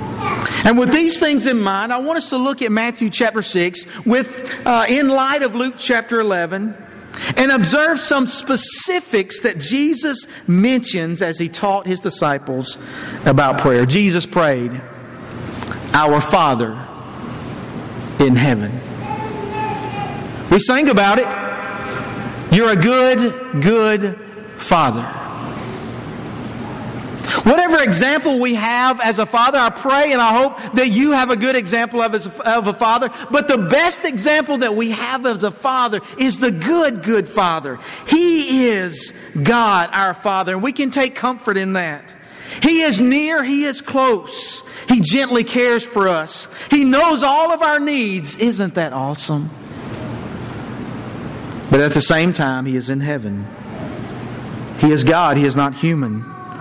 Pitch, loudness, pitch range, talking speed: 225 Hz, -16 LUFS, 175-260 Hz, 145 wpm